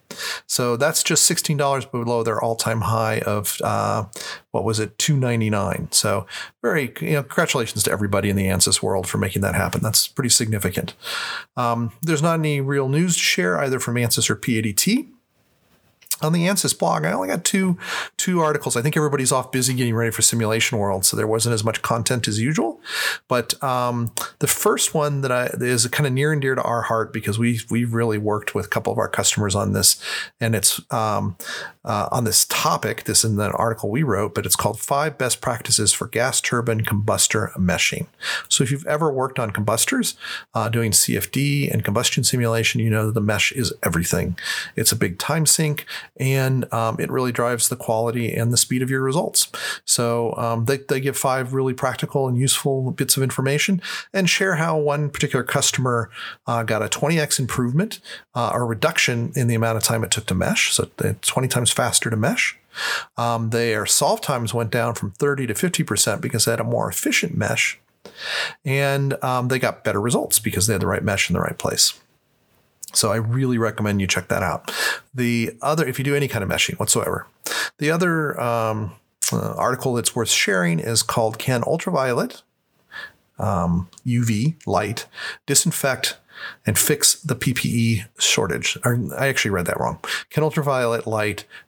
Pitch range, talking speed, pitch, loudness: 110-140 Hz, 190 wpm, 120 Hz, -20 LUFS